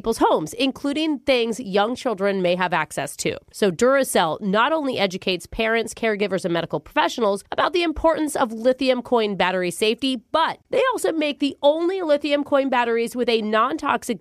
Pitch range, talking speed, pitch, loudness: 205-285 Hz, 175 wpm, 240 Hz, -21 LUFS